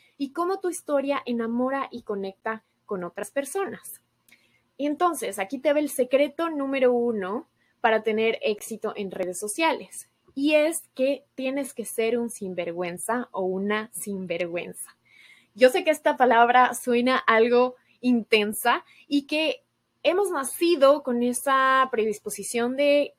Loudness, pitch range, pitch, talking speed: -25 LUFS, 215-285 Hz, 250 Hz, 135 wpm